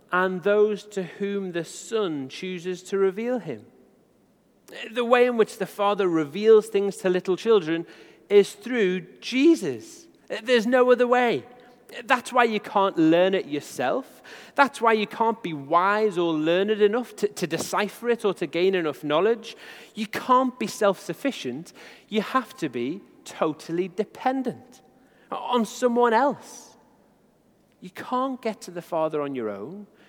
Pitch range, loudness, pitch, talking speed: 180-240 Hz, -24 LUFS, 205 Hz, 150 wpm